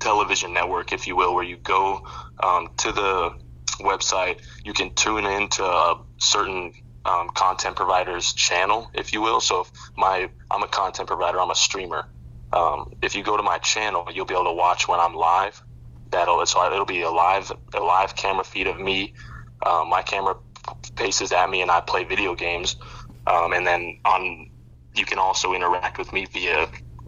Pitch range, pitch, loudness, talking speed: 60-95 Hz, 85 Hz, -22 LUFS, 185 wpm